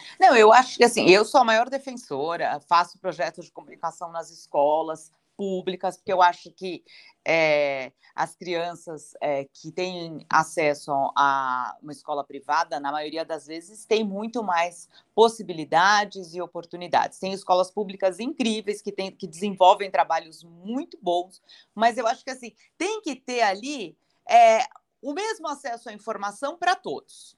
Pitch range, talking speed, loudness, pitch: 165-230 Hz, 155 wpm, -23 LUFS, 185 Hz